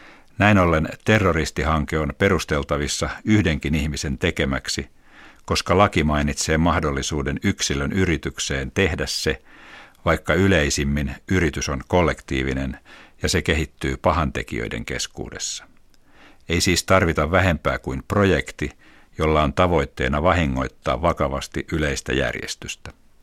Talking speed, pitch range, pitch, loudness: 100 wpm, 70-90 Hz, 80 Hz, -21 LUFS